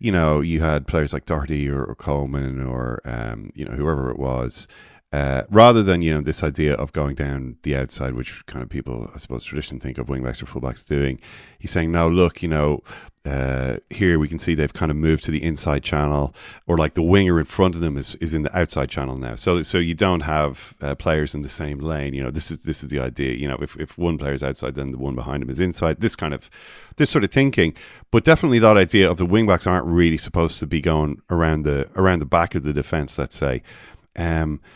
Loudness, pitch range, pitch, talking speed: -21 LUFS, 70-85 Hz, 75 Hz, 245 wpm